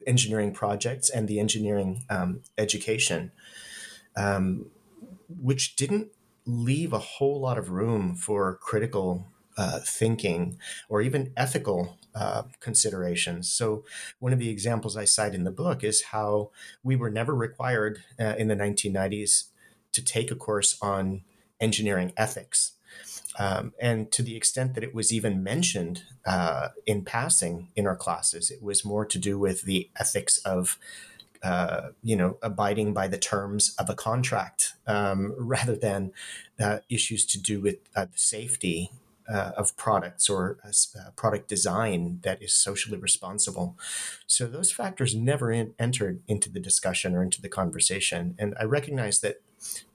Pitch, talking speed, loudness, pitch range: 105 Hz, 150 wpm, -27 LUFS, 100-120 Hz